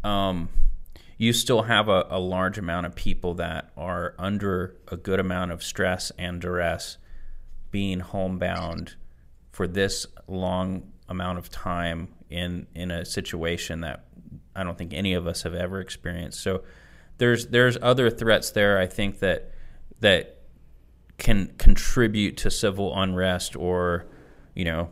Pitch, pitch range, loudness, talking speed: 90 Hz, 85-95 Hz, -26 LUFS, 145 wpm